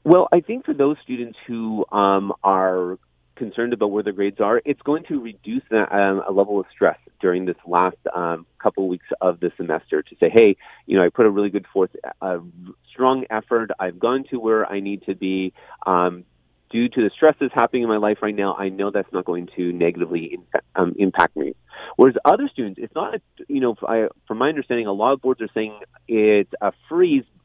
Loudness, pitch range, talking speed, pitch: -21 LUFS, 95-130 Hz, 210 wpm, 105 Hz